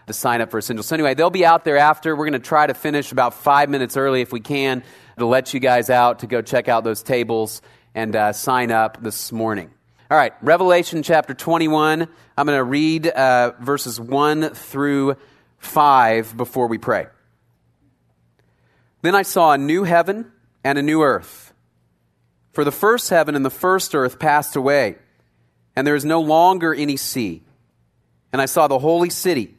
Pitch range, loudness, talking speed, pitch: 115-155 Hz, -18 LUFS, 185 wpm, 135 Hz